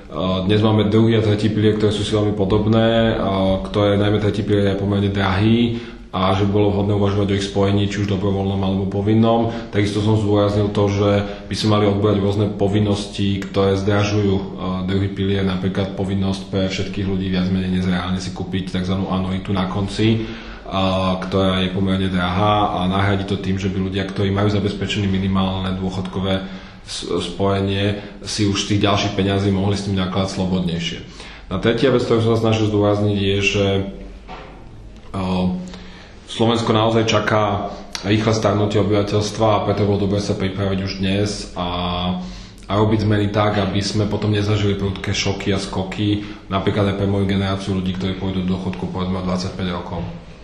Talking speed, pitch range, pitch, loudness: 165 wpm, 95-105 Hz, 100 Hz, -19 LUFS